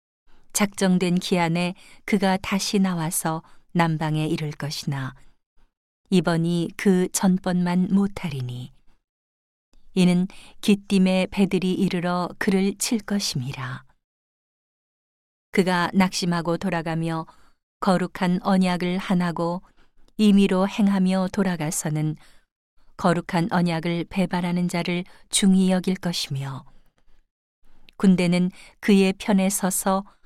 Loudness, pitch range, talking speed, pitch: -23 LUFS, 165-190 Hz, 215 characters per minute, 180 Hz